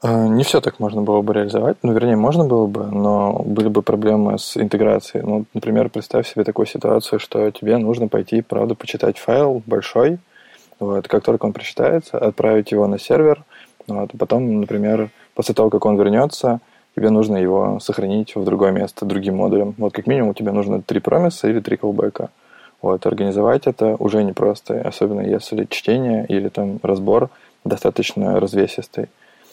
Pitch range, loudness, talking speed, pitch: 105-115 Hz, -18 LUFS, 165 wpm, 105 Hz